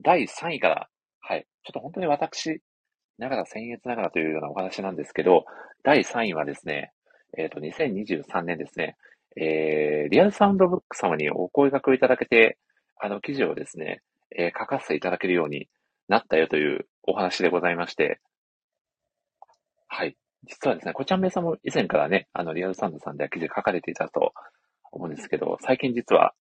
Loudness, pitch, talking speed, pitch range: -25 LUFS, 120 Hz, 375 characters per minute, 85-145 Hz